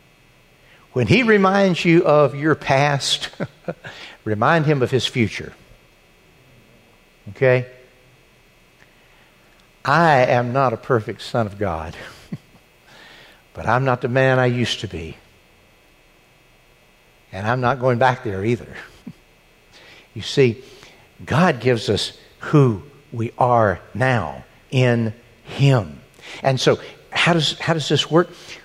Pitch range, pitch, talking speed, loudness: 110-145 Hz, 125 Hz, 115 wpm, -19 LUFS